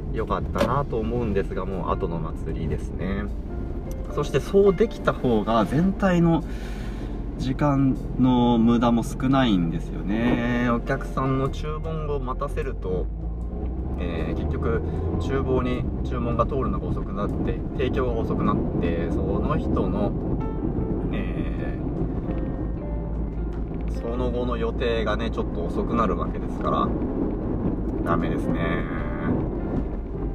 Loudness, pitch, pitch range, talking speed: -25 LUFS, 95 Hz, 80-130 Hz, 240 characters per minute